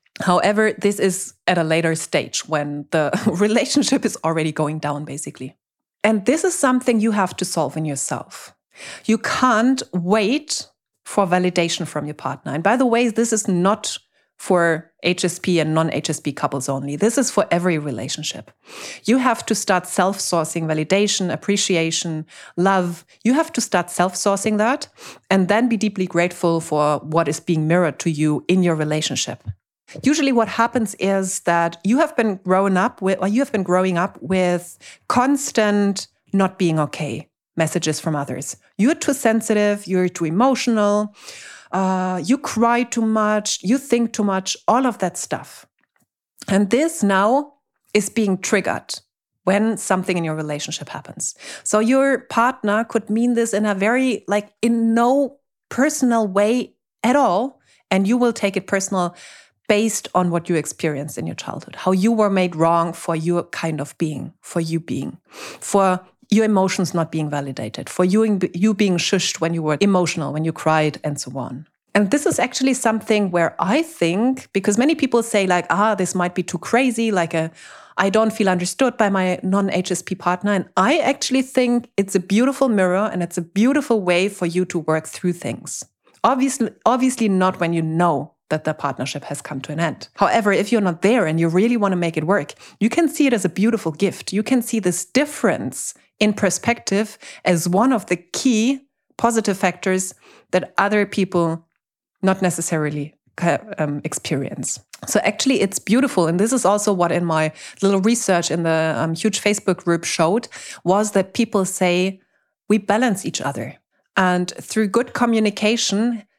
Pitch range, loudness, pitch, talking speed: 170-225 Hz, -19 LUFS, 190 Hz, 175 wpm